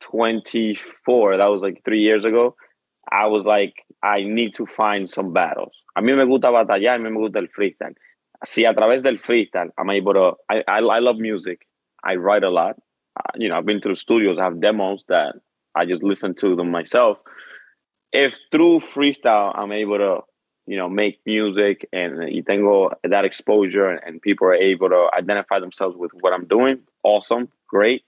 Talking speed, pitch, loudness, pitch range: 175 wpm, 105 Hz, -19 LUFS, 100-115 Hz